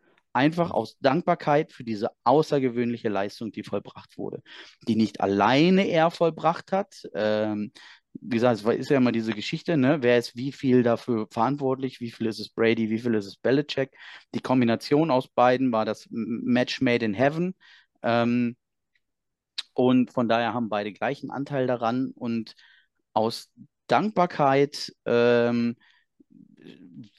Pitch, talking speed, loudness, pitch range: 120 Hz, 145 wpm, -25 LUFS, 115-140 Hz